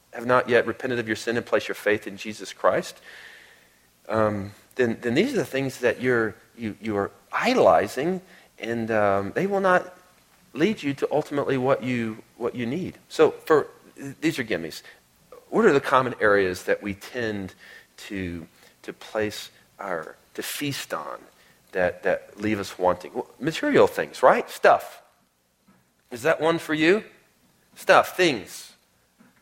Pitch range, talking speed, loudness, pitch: 105-140 Hz, 160 wpm, -24 LUFS, 115 Hz